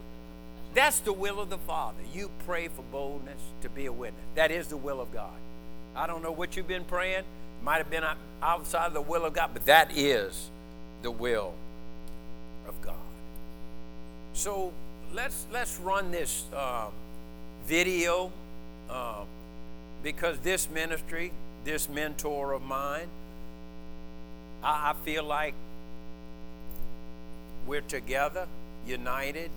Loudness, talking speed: -31 LUFS, 135 wpm